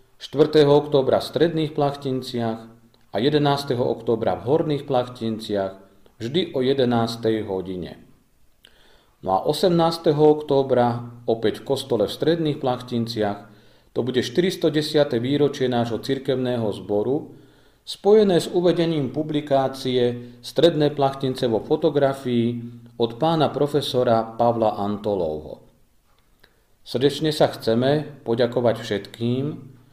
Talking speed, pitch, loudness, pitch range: 100 wpm, 130 Hz, -22 LUFS, 115-145 Hz